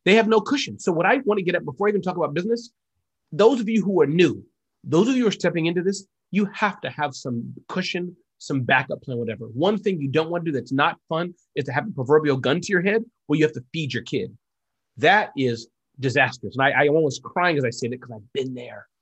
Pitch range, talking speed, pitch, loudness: 130-195 Hz, 260 wpm, 160 Hz, -22 LUFS